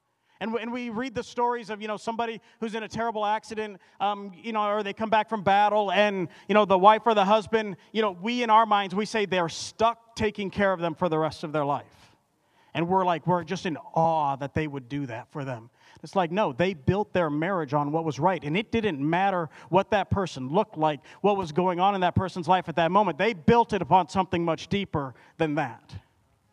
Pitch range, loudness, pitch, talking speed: 165-215 Hz, -26 LUFS, 195 Hz, 240 wpm